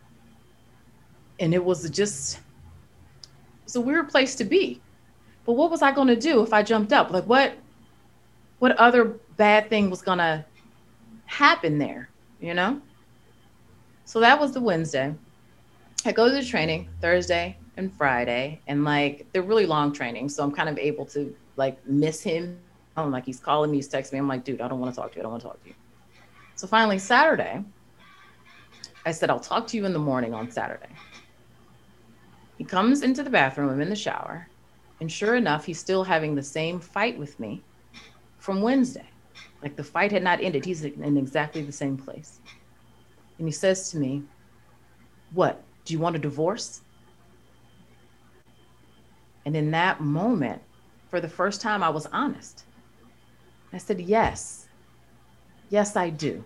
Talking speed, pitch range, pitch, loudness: 170 wpm, 140-215 Hz, 165 Hz, -24 LUFS